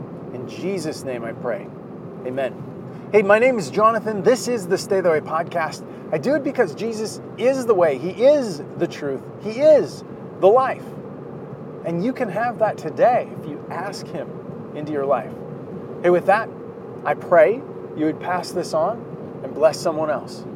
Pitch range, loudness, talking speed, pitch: 170-240 Hz, -21 LUFS, 180 wpm, 205 Hz